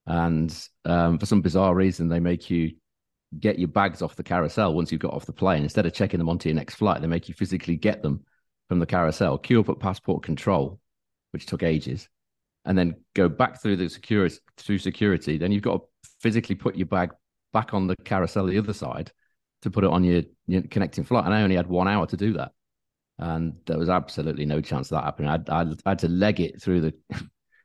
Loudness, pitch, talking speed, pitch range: -25 LUFS, 90 Hz, 230 wpm, 80-100 Hz